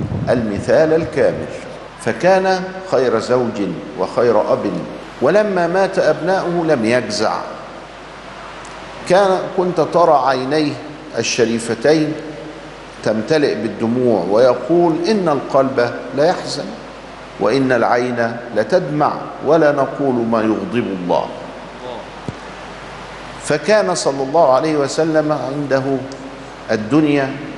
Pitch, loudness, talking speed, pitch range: 145 Hz, -16 LUFS, 85 wpm, 125-160 Hz